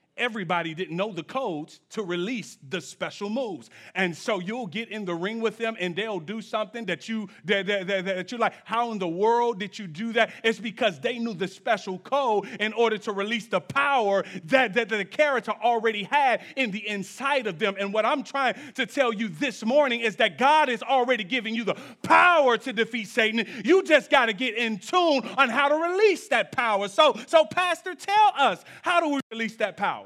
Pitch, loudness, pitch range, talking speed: 225 Hz, -25 LUFS, 205-265 Hz, 215 wpm